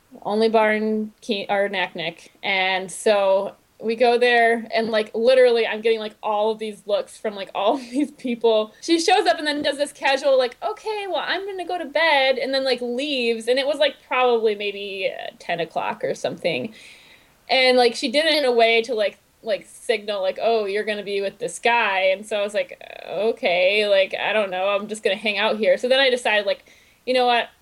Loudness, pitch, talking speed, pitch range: -21 LUFS, 230 Hz, 220 wpm, 210-280 Hz